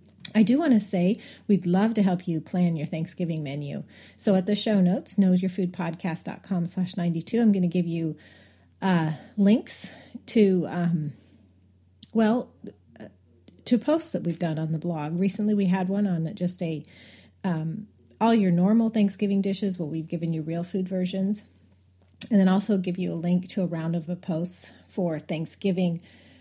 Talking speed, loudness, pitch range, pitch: 175 wpm, -26 LUFS, 160-200 Hz, 180 Hz